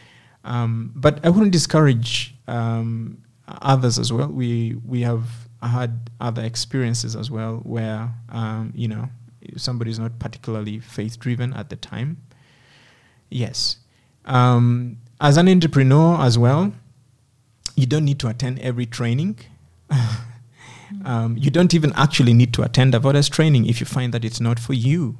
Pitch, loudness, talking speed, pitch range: 120 Hz, -20 LUFS, 150 wpm, 115-135 Hz